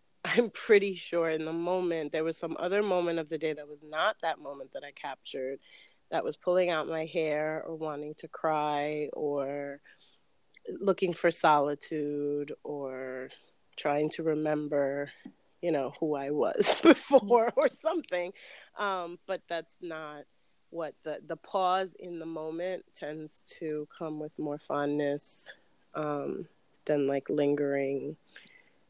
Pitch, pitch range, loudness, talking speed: 155 Hz, 145-175 Hz, -31 LUFS, 145 wpm